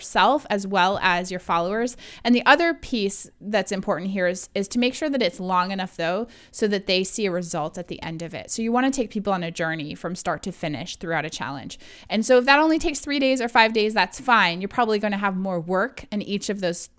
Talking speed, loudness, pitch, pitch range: 260 wpm, -23 LUFS, 200 Hz, 180-235 Hz